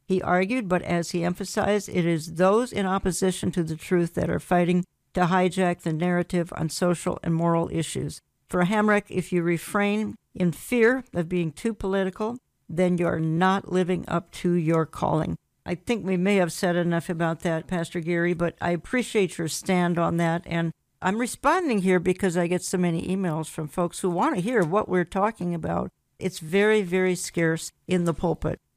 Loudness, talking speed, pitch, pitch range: -25 LUFS, 190 wpm, 180 Hz, 170-190 Hz